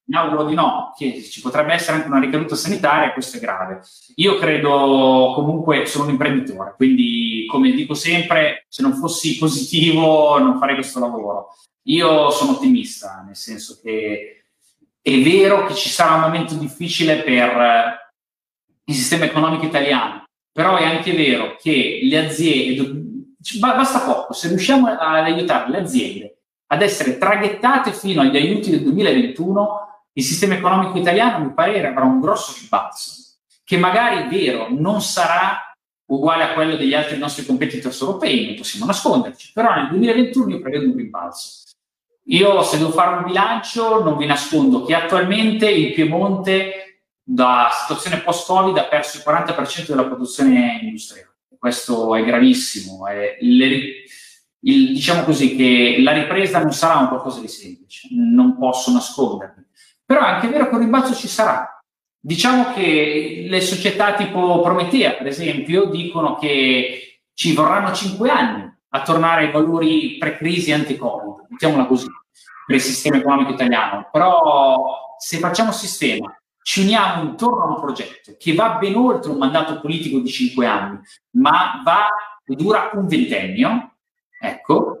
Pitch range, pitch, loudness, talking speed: 140-225 Hz, 165 Hz, -17 LUFS, 150 wpm